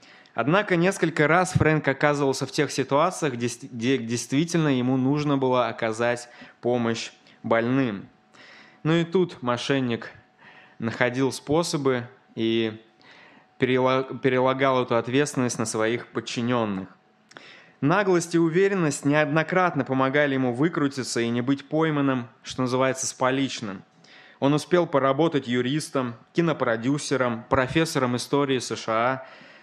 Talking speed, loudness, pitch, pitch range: 105 wpm, -24 LUFS, 130 Hz, 120-150 Hz